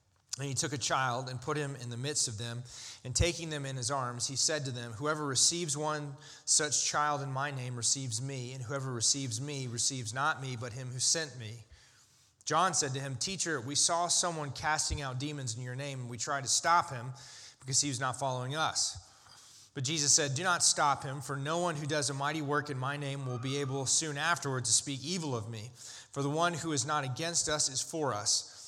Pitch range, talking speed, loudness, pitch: 125-150 Hz, 230 wpm, -31 LUFS, 140 Hz